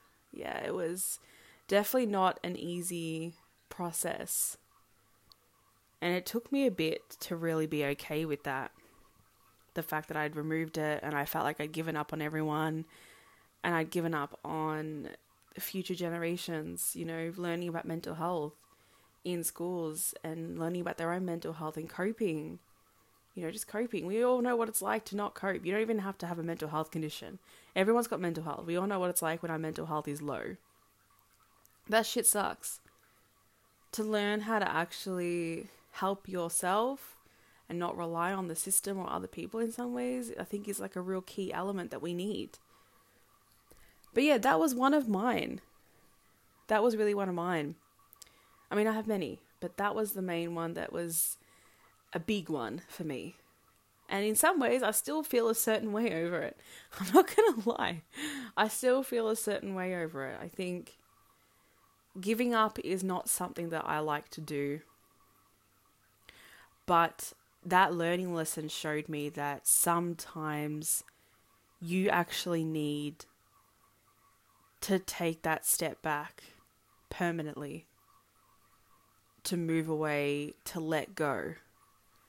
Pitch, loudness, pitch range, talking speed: 175 Hz, -33 LUFS, 155-205 Hz, 160 wpm